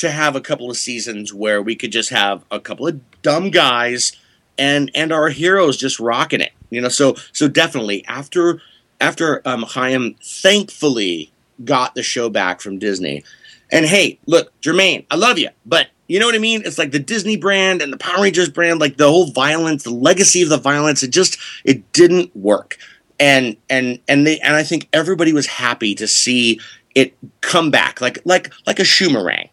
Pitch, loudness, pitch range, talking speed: 140 Hz, -15 LUFS, 120-165 Hz, 195 wpm